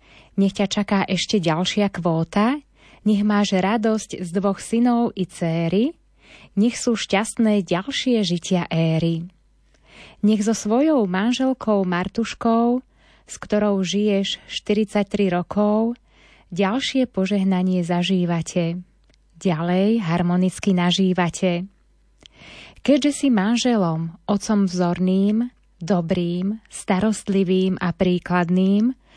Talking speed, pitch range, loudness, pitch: 95 wpm, 180-220 Hz, -21 LUFS, 195 Hz